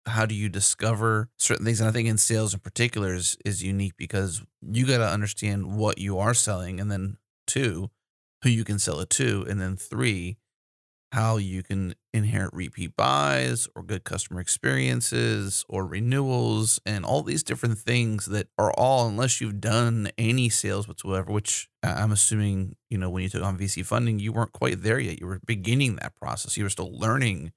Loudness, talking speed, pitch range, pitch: -25 LUFS, 190 wpm, 95-115 Hz, 105 Hz